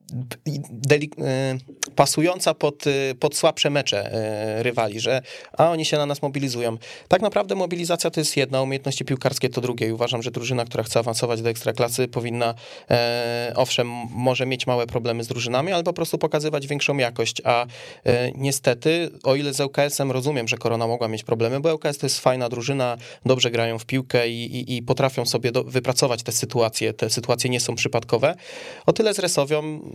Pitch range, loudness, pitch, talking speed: 120-145 Hz, -23 LUFS, 130 Hz, 185 wpm